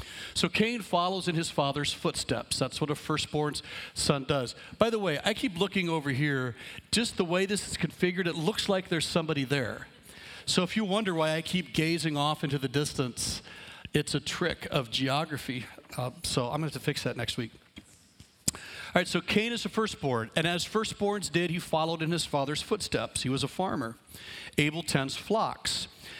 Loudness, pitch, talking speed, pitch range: -30 LUFS, 160 Hz, 195 wpm, 140-180 Hz